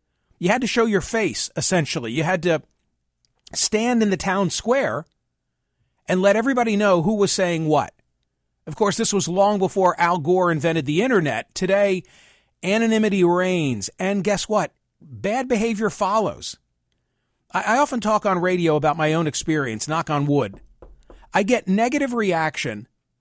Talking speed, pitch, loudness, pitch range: 155 wpm, 185 Hz, -21 LUFS, 155-210 Hz